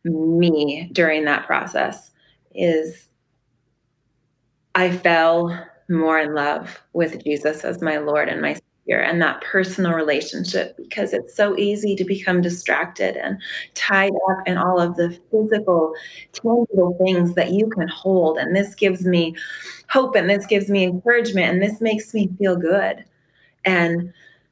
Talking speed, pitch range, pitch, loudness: 145 wpm, 160-195 Hz, 175 Hz, -20 LUFS